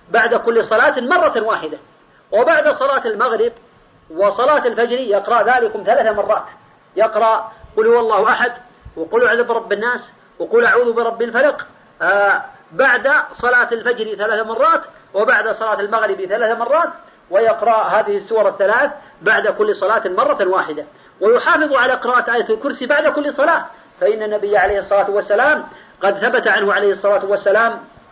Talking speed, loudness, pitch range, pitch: 140 wpm, -15 LUFS, 215-290 Hz, 235 Hz